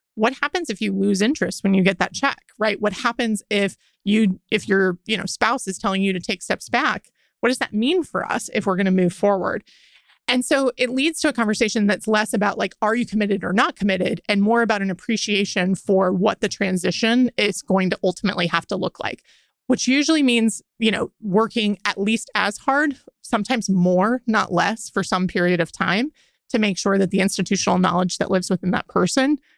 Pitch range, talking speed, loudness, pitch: 190-235 Hz, 215 wpm, -21 LUFS, 210 Hz